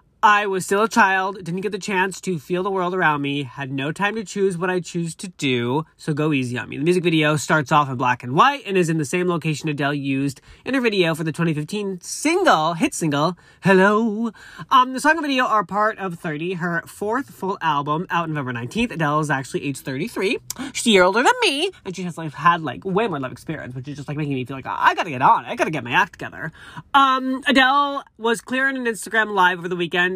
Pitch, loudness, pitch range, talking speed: 180 Hz, -20 LUFS, 150-215 Hz, 245 wpm